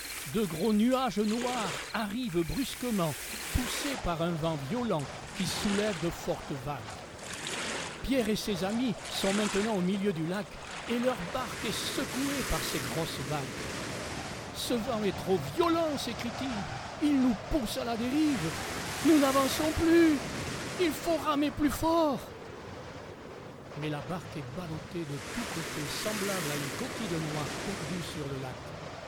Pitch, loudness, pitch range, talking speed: 220 Hz, -31 LUFS, 180-270 Hz, 150 wpm